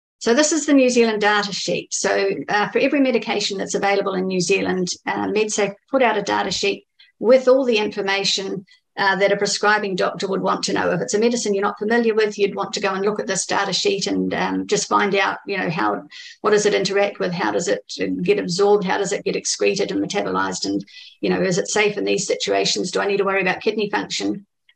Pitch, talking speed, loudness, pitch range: 205 Hz, 240 wpm, -20 LUFS, 195-225 Hz